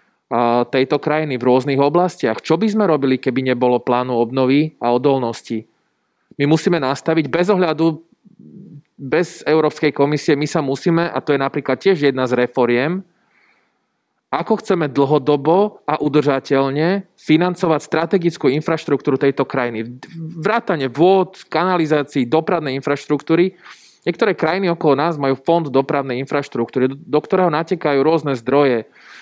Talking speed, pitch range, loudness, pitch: 125 wpm, 135-170 Hz, -17 LUFS, 150 Hz